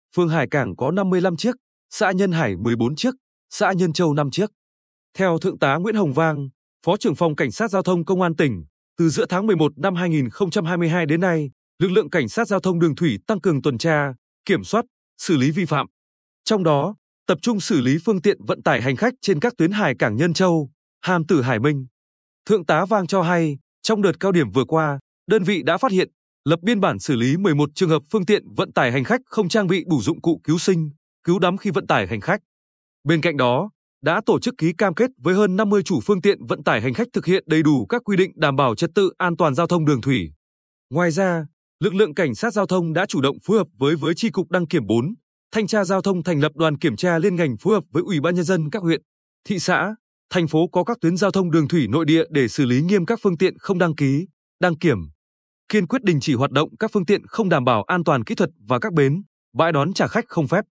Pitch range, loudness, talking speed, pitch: 150-200 Hz, -20 LUFS, 250 wpm, 175 Hz